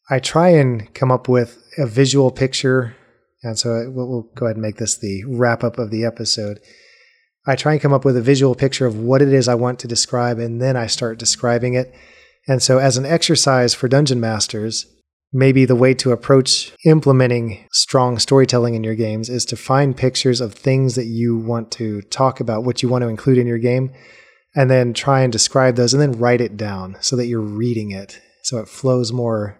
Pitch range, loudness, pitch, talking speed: 115-130 Hz, -17 LUFS, 125 Hz, 215 wpm